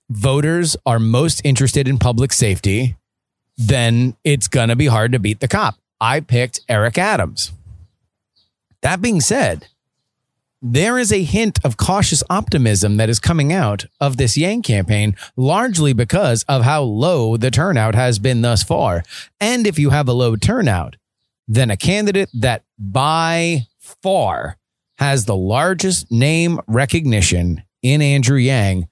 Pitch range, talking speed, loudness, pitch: 110-145 Hz, 145 wpm, -16 LUFS, 125 Hz